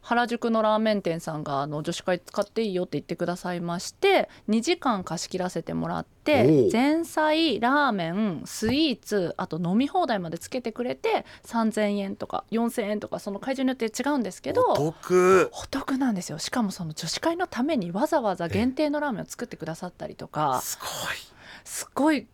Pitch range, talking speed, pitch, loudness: 180-265 Hz, 375 characters per minute, 220 Hz, -26 LUFS